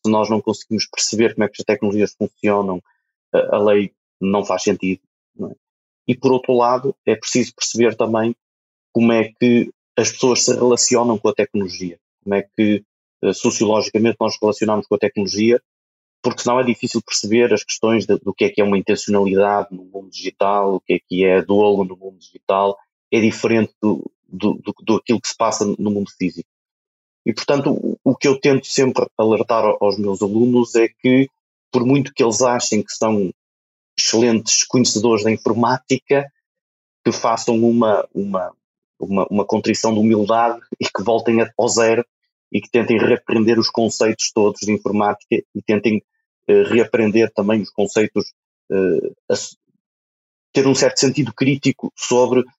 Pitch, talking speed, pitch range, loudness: 110 Hz, 165 wpm, 100-120 Hz, -18 LUFS